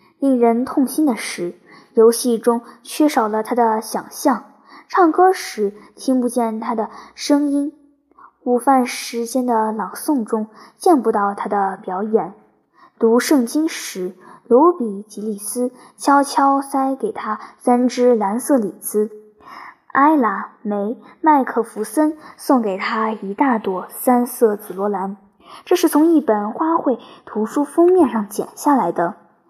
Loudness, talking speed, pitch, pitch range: -18 LUFS, 195 characters per minute, 240 Hz, 215-285 Hz